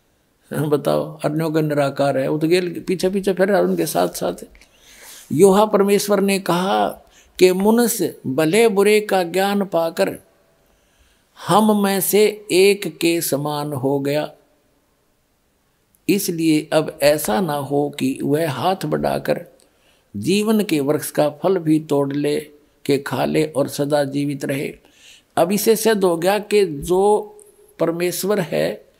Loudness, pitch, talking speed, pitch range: -19 LUFS, 170 Hz, 135 wpm, 145-200 Hz